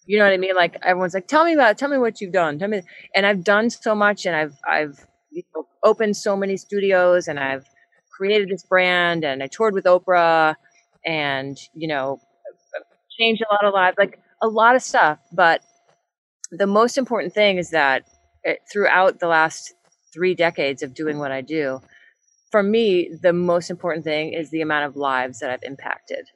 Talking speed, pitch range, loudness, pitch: 205 wpm, 155-210 Hz, -19 LUFS, 185 Hz